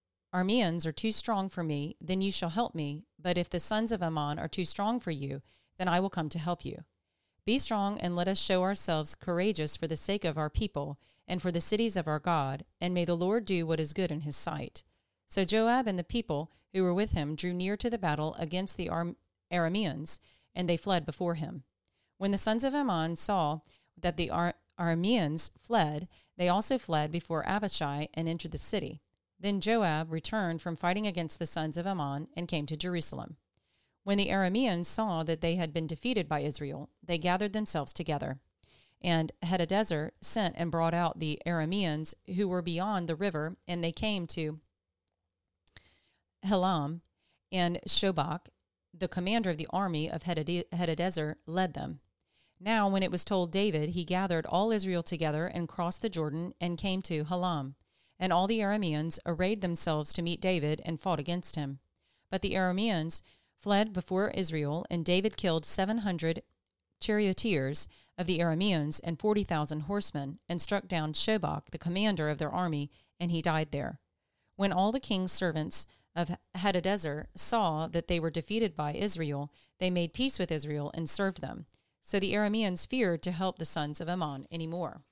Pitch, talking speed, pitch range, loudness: 175 Hz, 180 wpm, 155-190 Hz, -32 LUFS